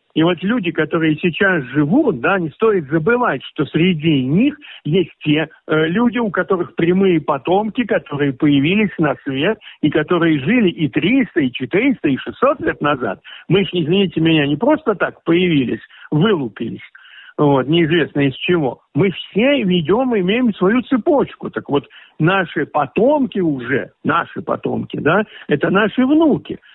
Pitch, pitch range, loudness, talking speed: 175 Hz, 155-215 Hz, -17 LUFS, 150 wpm